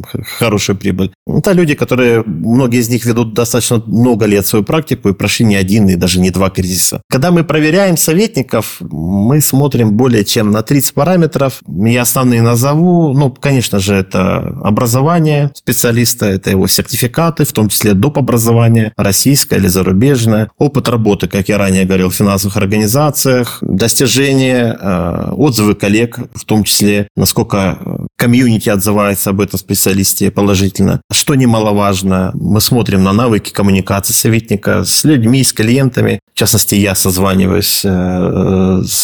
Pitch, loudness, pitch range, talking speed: 110 Hz, -11 LUFS, 100-130 Hz, 145 wpm